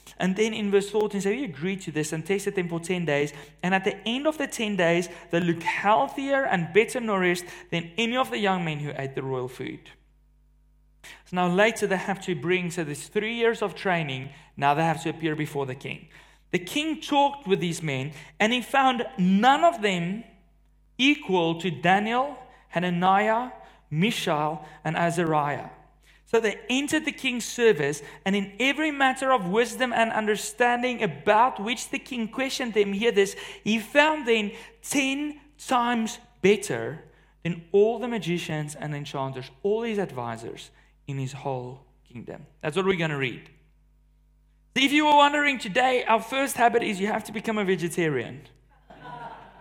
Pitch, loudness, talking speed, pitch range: 195 Hz, -25 LUFS, 175 wpm, 155-230 Hz